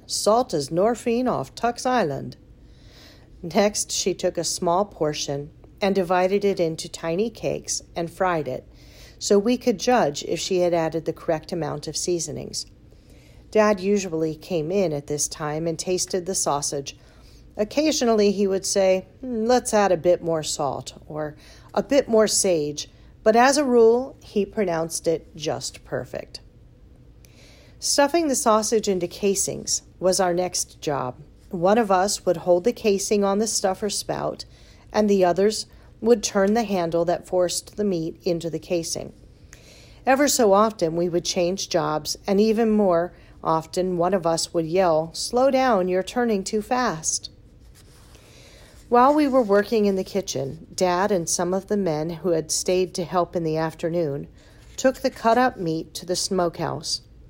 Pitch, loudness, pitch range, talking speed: 185 Hz, -22 LUFS, 165-215 Hz, 160 wpm